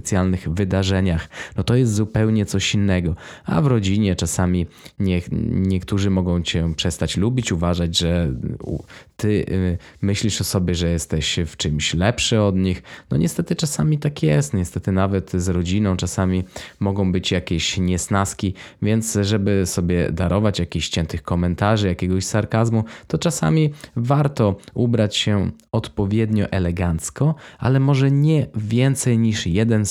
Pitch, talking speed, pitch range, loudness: 100 Hz, 135 wpm, 90-110 Hz, -20 LUFS